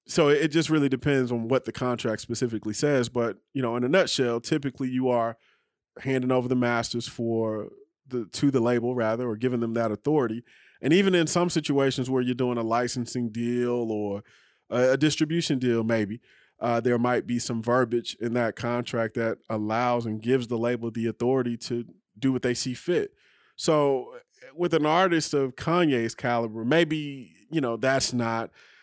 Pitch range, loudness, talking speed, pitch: 115-140 Hz, -26 LUFS, 180 wpm, 125 Hz